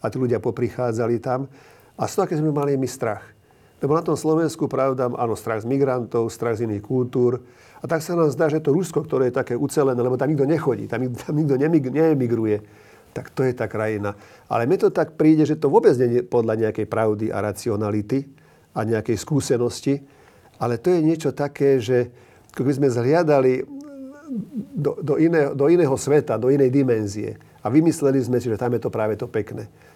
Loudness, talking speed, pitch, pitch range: -21 LUFS, 200 wpm, 130 Hz, 115-150 Hz